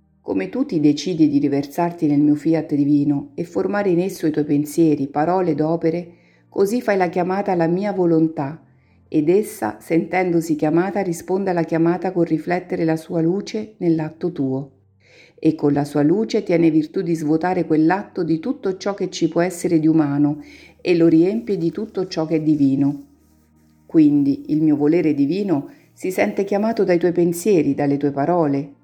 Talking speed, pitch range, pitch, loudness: 175 wpm, 150-185 Hz, 165 Hz, -19 LUFS